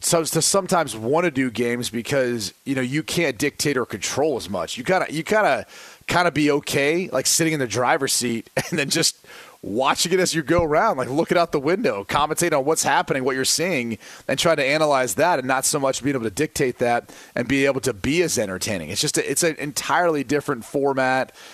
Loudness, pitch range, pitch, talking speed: -21 LUFS, 130-165 Hz, 145 Hz, 240 wpm